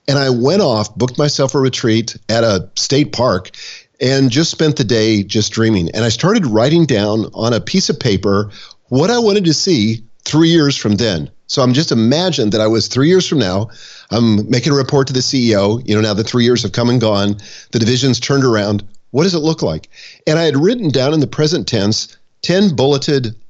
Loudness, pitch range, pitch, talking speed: -14 LUFS, 110-145 Hz, 120 Hz, 220 wpm